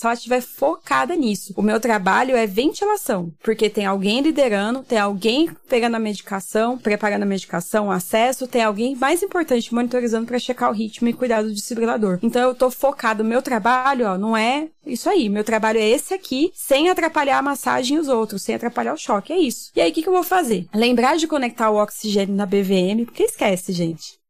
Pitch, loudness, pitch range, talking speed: 235 Hz, -20 LUFS, 215-270 Hz, 205 wpm